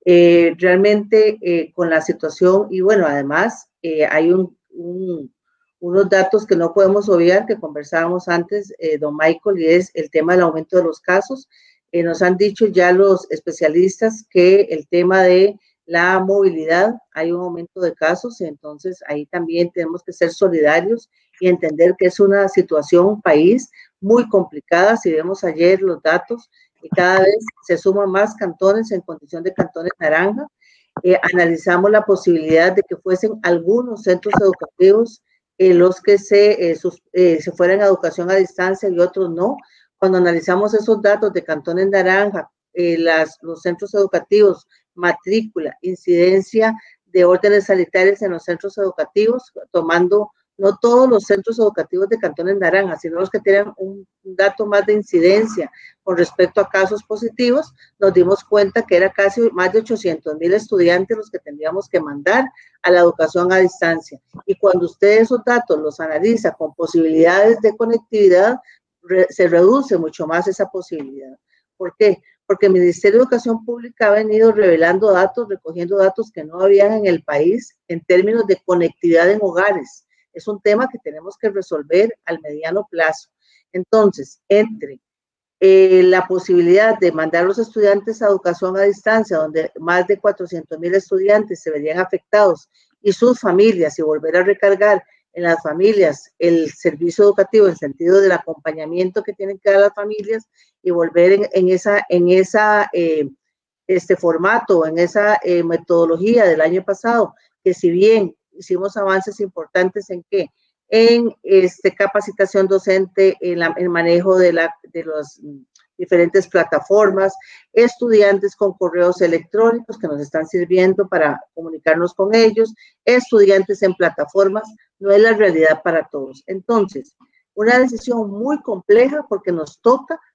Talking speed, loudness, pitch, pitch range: 155 wpm, -15 LUFS, 190 Hz, 175-205 Hz